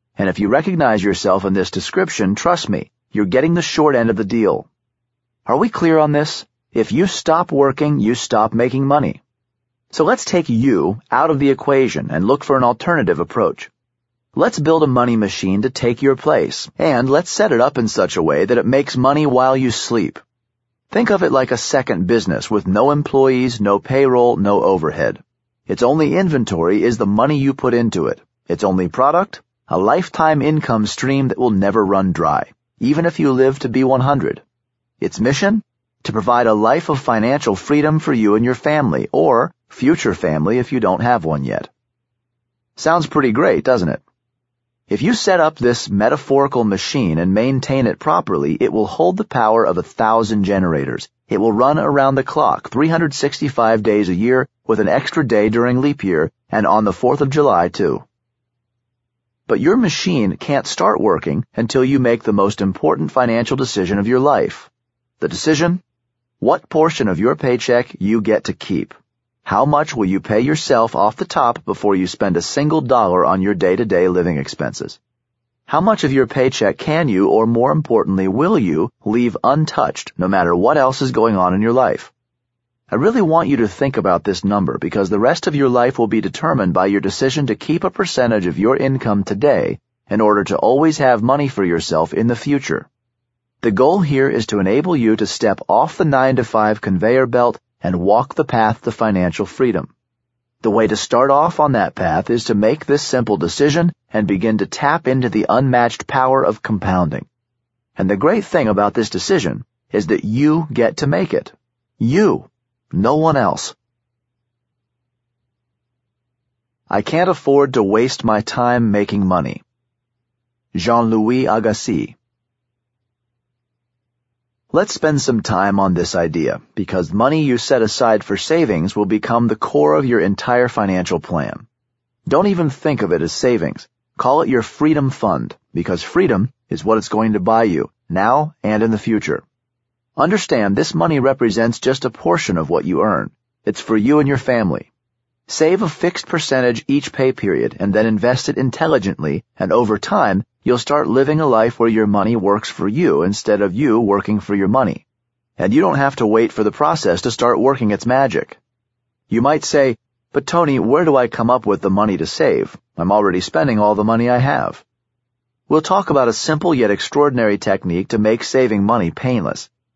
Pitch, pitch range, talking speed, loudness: 120 Hz, 110-135 Hz, 185 wpm, -16 LUFS